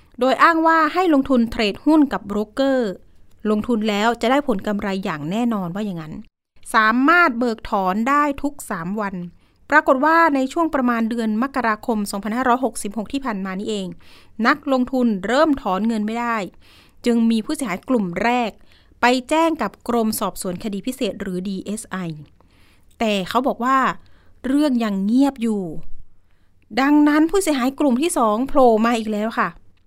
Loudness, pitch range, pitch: -19 LUFS, 205-265 Hz, 230 Hz